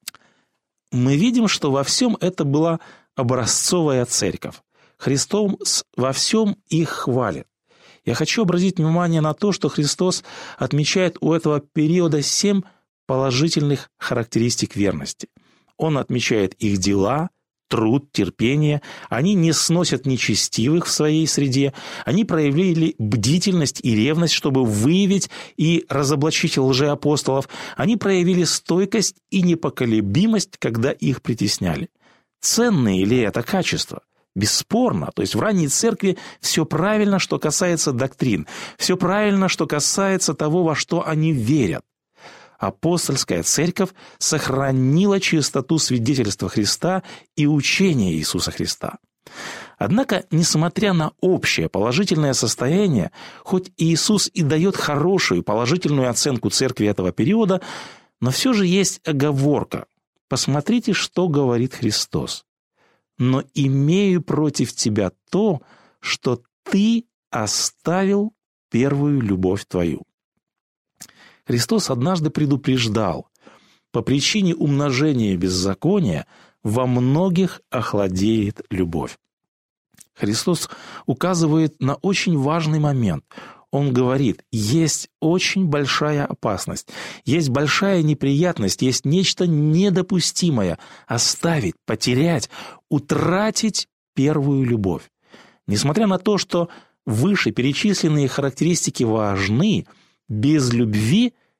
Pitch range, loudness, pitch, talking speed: 130-180 Hz, -20 LUFS, 150 Hz, 105 wpm